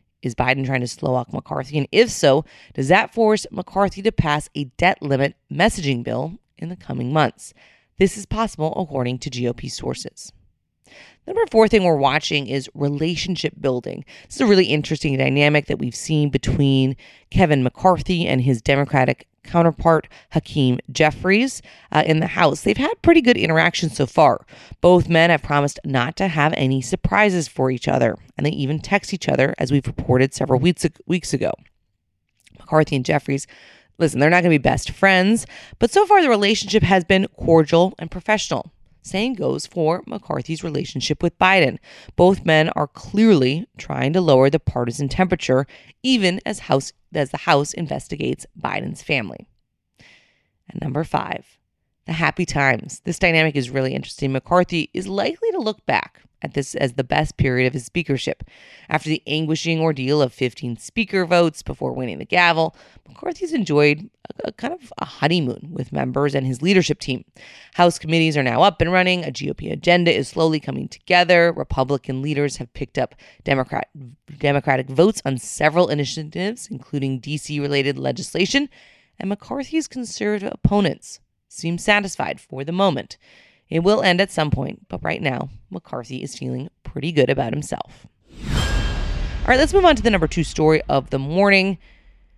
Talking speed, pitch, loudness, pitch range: 170 wpm, 155 Hz, -19 LUFS, 135-185 Hz